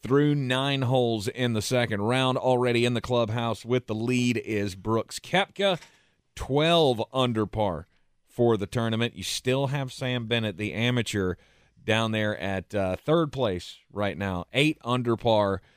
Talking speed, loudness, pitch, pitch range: 155 wpm, -26 LUFS, 120 Hz, 105-130 Hz